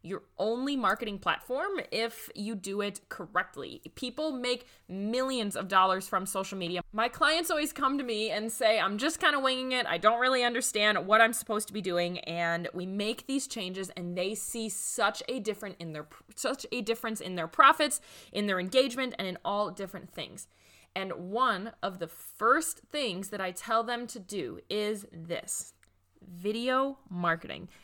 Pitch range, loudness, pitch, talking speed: 185-245 Hz, -30 LUFS, 215 Hz, 180 wpm